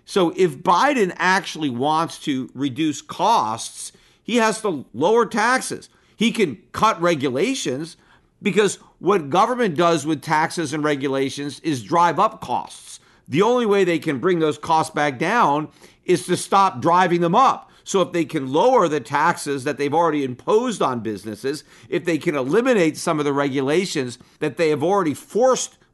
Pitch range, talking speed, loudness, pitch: 150-185 Hz, 165 wpm, -20 LUFS, 165 Hz